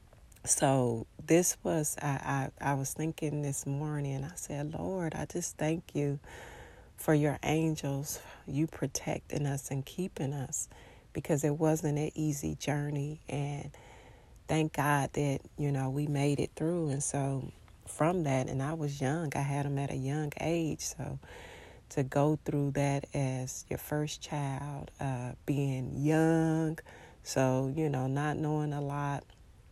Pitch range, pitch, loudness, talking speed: 135-155 Hz, 145 Hz, -33 LUFS, 155 wpm